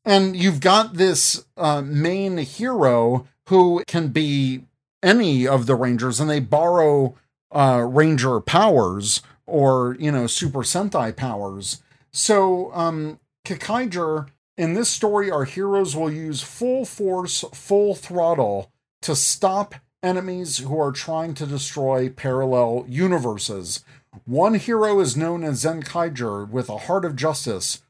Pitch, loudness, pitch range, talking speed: 150 Hz, -20 LUFS, 130-180 Hz, 130 wpm